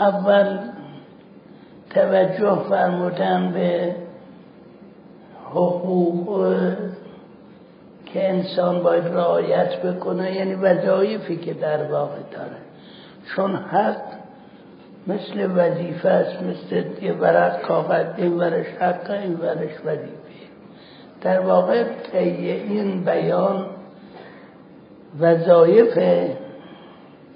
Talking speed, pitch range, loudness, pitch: 75 wpm, 170-190 Hz, -20 LUFS, 180 Hz